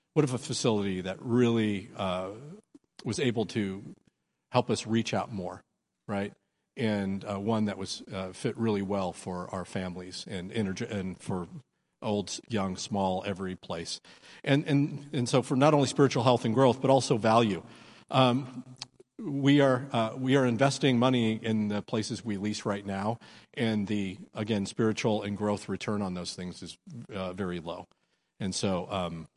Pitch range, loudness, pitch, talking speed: 95-125 Hz, -29 LUFS, 110 Hz, 170 wpm